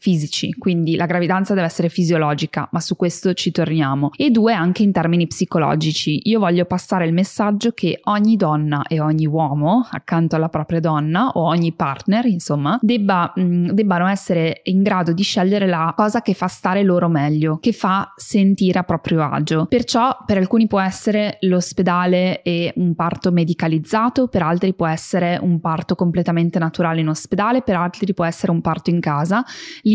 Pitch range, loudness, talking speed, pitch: 165-200 Hz, -18 LUFS, 170 wpm, 180 Hz